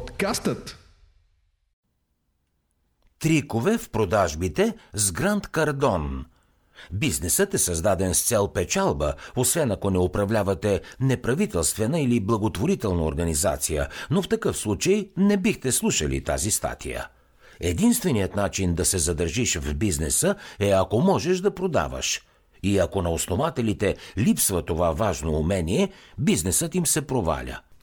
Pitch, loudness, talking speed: 100 Hz, -24 LUFS, 115 wpm